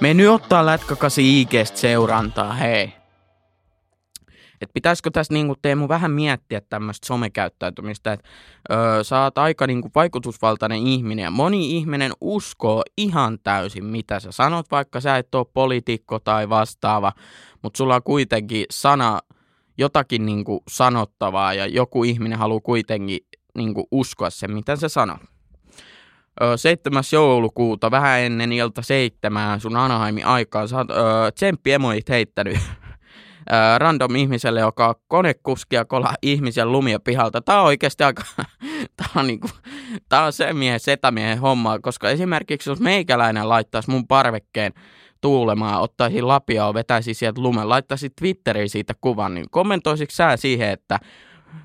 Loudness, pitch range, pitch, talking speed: -20 LUFS, 110-140 Hz, 120 Hz, 135 wpm